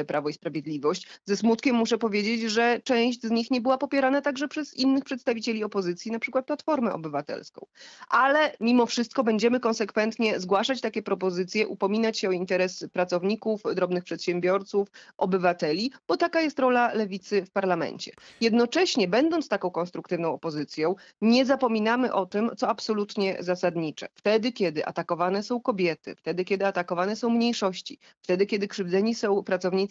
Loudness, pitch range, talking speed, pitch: -26 LUFS, 185-240 Hz, 145 wpm, 215 Hz